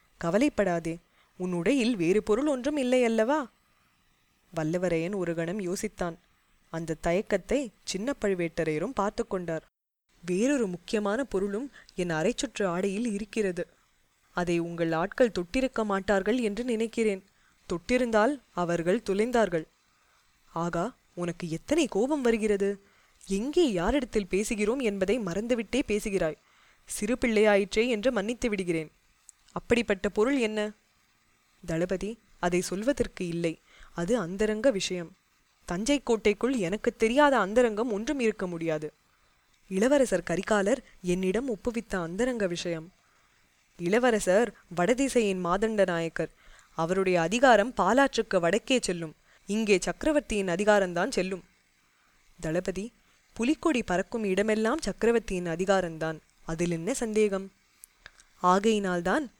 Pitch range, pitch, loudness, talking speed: 175-235 Hz, 200 Hz, -28 LUFS, 100 wpm